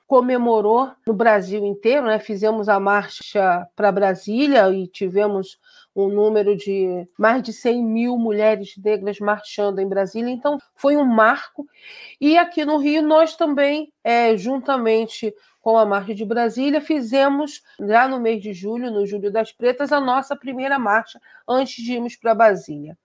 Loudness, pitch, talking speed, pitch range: -19 LUFS, 225 Hz, 155 wpm, 205-275 Hz